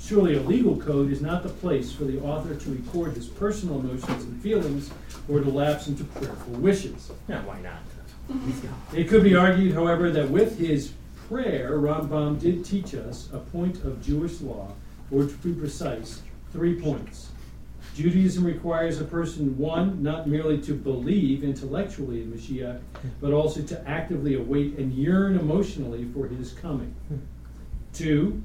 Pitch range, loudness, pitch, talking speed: 135-170 Hz, -26 LUFS, 150 Hz, 160 wpm